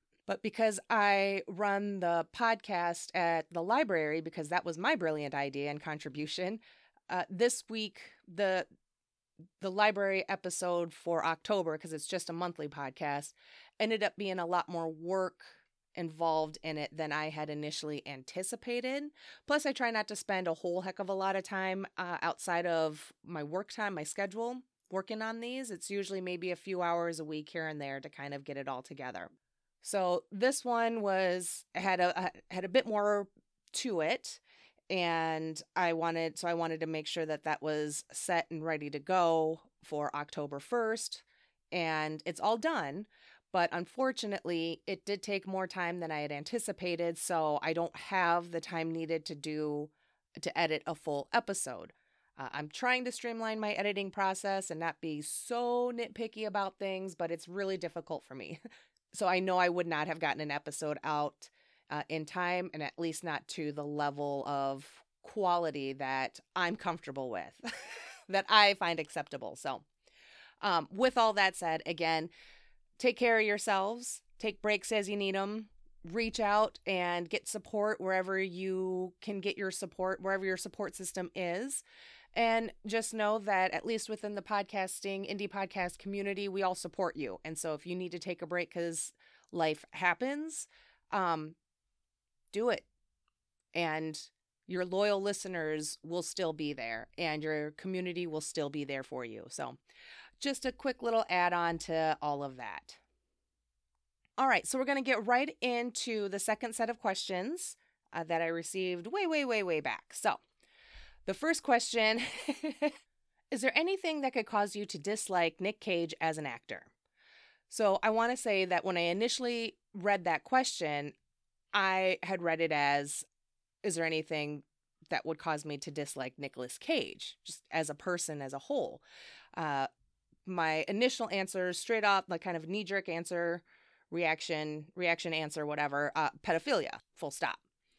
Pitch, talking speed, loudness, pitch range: 180 Hz, 170 wpm, -34 LUFS, 160-205 Hz